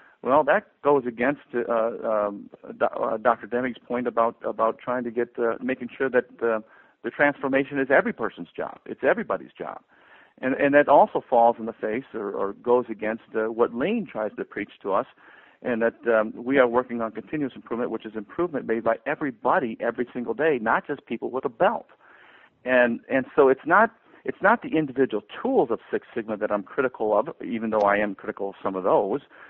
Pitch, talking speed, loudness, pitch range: 120 Hz, 200 wpm, -25 LUFS, 110-130 Hz